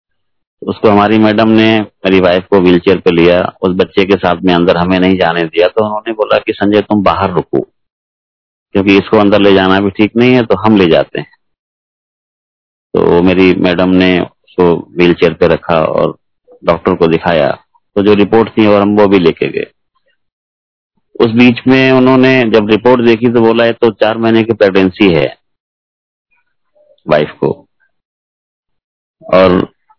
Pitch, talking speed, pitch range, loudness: 105 Hz, 165 wpm, 95-115 Hz, -9 LUFS